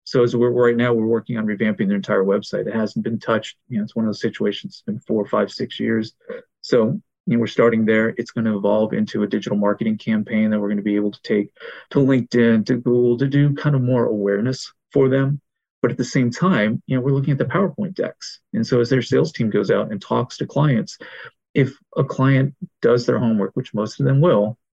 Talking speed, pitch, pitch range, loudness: 240 wpm, 120 Hz, 110-135 Hz, -20 LUFS